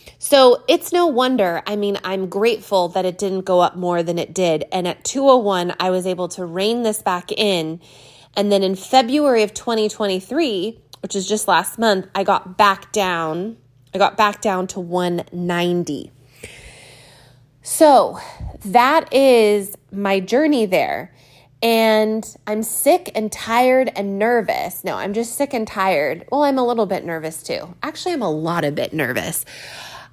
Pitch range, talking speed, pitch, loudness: 180-230 Hz, 165 wpm, 200 Hz, -18 LUFS